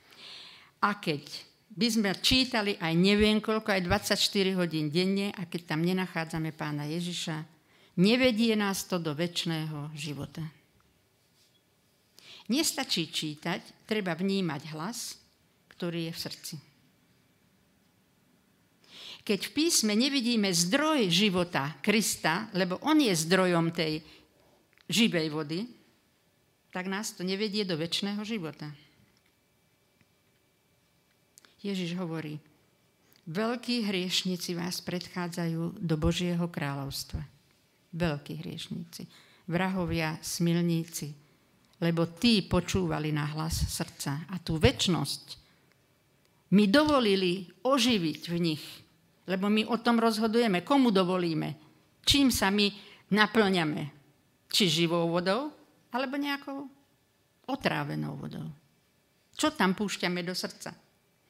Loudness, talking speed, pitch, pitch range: -29 LUFS, 100 wpm, 180 Hz, 160-205 Hz